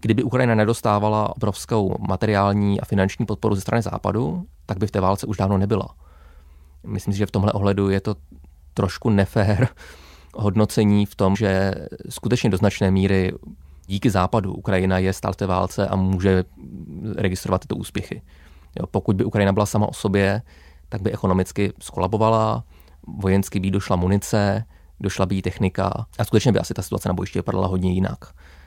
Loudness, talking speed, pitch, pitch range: -22 LUFS, 170 wpm, 100 Hz, 95-105 Hz